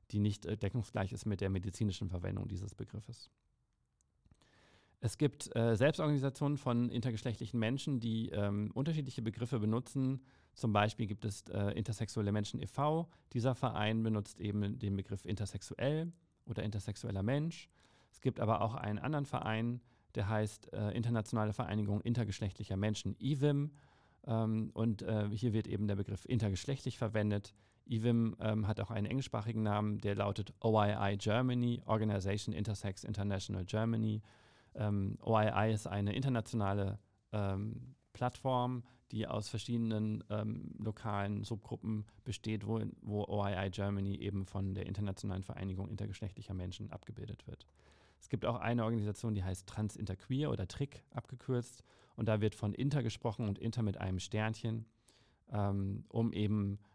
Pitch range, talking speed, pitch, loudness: 100-120 Hz, 140 wpm, 110 Hz, -38 LUFS